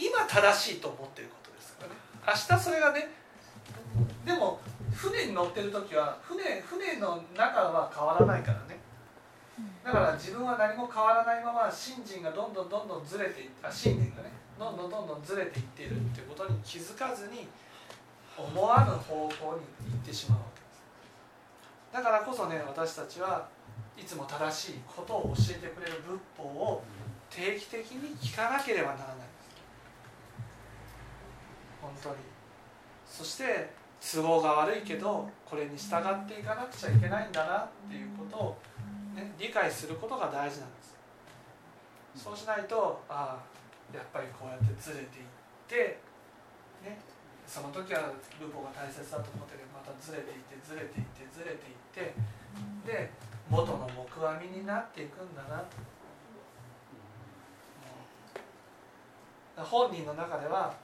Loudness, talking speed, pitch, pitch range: -33 LUFS, 300 characters per minute, 155 Hz, 120-205 Hz